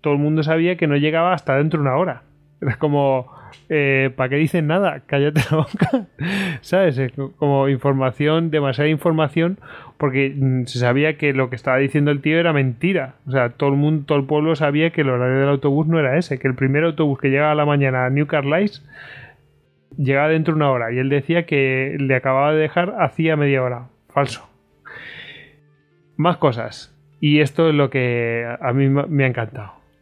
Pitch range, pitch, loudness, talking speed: 135-155 Hz, 145 Hz, -19 LUFS, 195 wpm